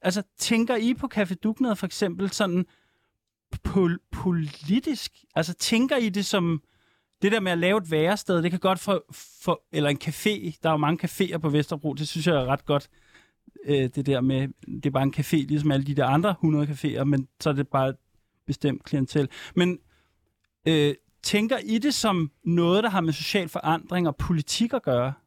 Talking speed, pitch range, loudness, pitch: 190 wpm, 140-195 Hz, -25 LUFS, 160 Hz